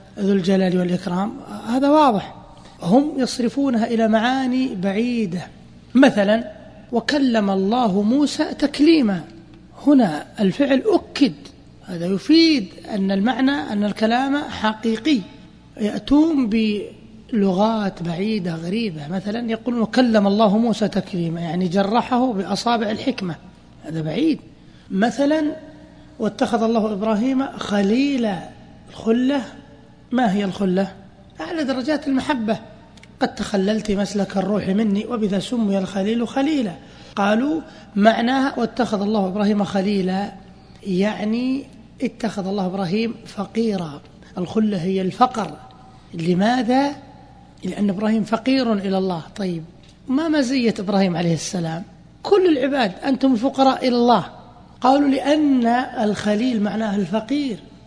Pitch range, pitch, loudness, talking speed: 195-255 Hz, 220 Hz, -20 LUFS, 105 wpm